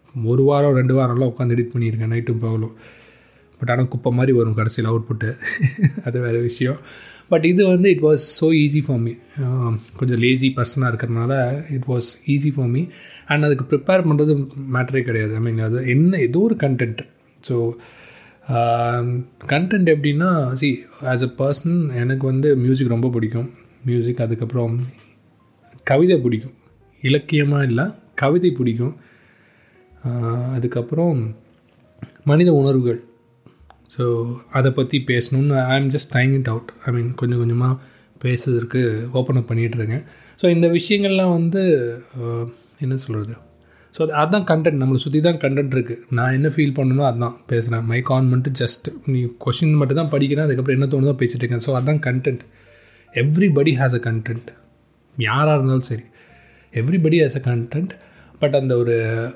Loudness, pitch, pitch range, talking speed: -19 LUFS, 130 Hz, 120-145 Hz, 140 wpm